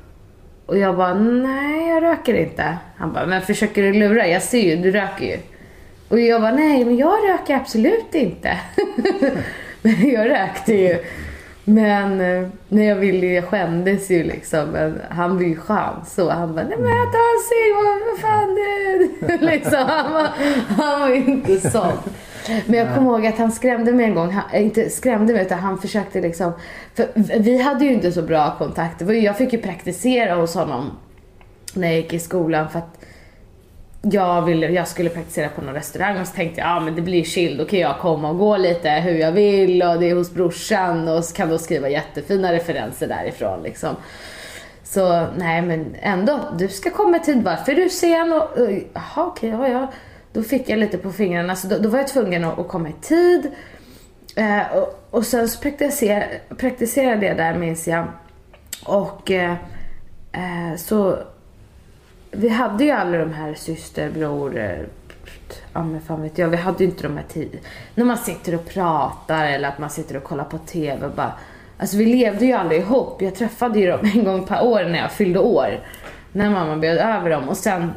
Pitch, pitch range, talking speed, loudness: 190 Hz, 165-235 Hz, 190 wpm, -19 LUFS